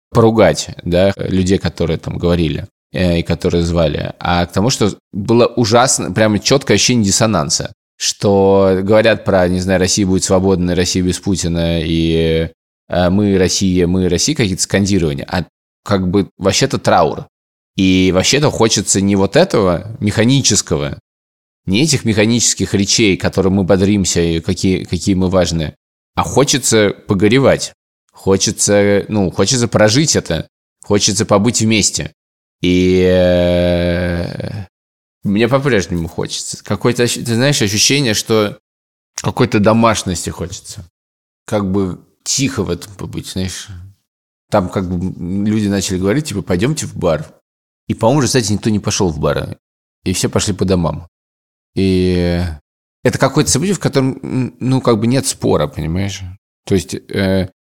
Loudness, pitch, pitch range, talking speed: -14 LUFS, 95 Hz, 85-110 Hz, 135 wpm